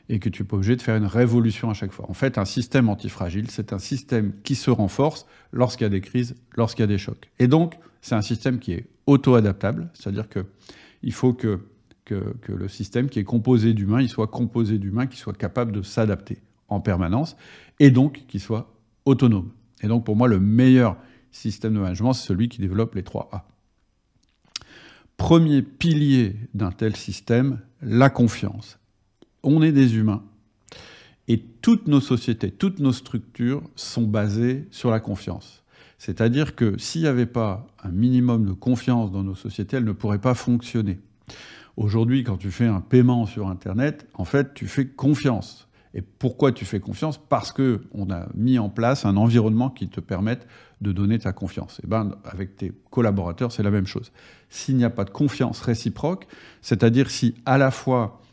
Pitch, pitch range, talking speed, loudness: 115 Hz, 105-125 Hz, 185 wpm, -22 LUFS